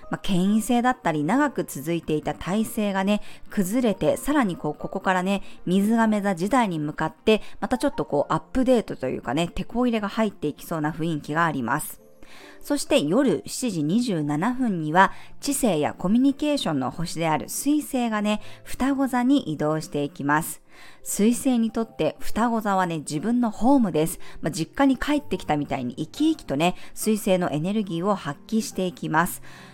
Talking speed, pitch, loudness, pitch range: 365 characters per minute, 200 Hz, -24 LUFS, 160-245 Hz